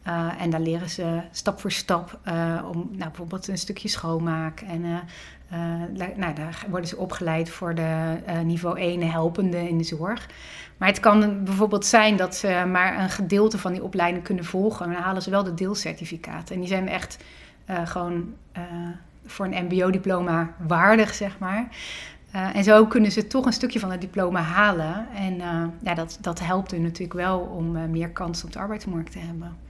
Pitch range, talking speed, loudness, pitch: 170-195 Hz, 195 wpm, -24 LUFS, 180 Hz